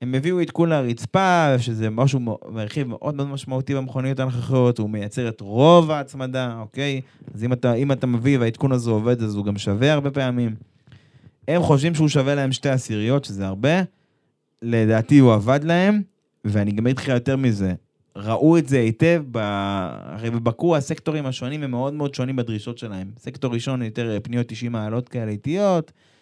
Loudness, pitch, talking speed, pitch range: -21 LUFS, 130 Hz, 165 wpm, 115-140 Hz